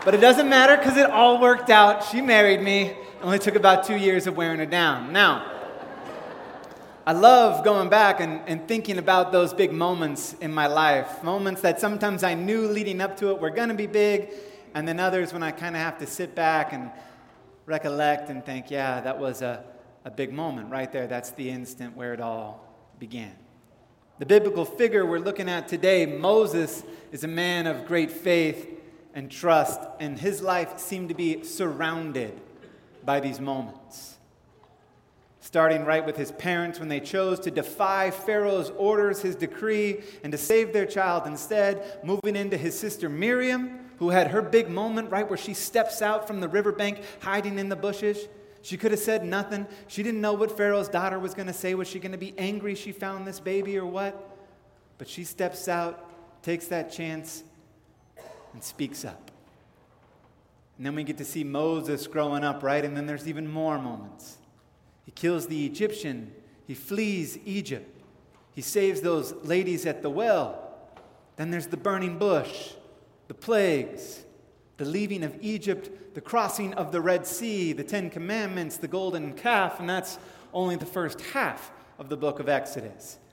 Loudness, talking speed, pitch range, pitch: -24 LUFS, 180 wpm, 150-200 Hz, 180 Hz